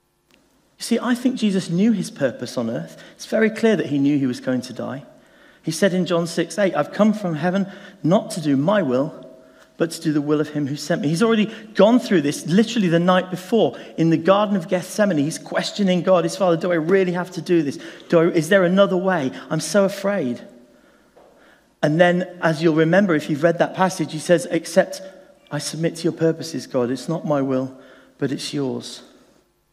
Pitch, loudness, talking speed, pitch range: 175 Hz, -20 LUFS, 215 wpm, 160-195 Hz